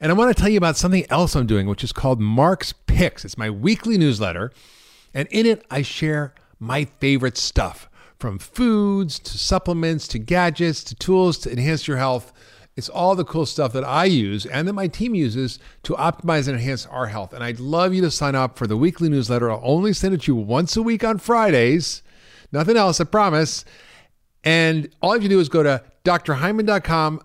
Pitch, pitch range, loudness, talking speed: 155 Hz, 130-180 Hz, -20 LUFS, 215 wpm